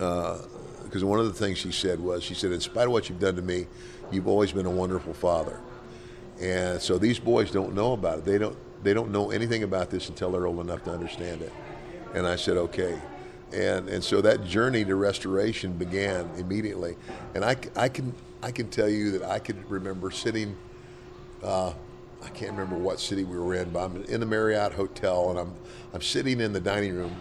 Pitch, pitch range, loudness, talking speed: 95 Hz, 90-105 Hz, -28 LUFS, 215 wpm